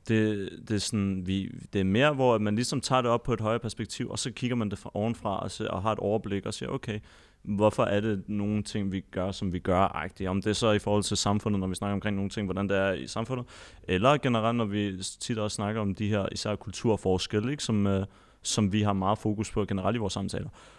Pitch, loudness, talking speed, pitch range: 105 Hz, -29 LUFS, 255 wpm, 100-110 Hz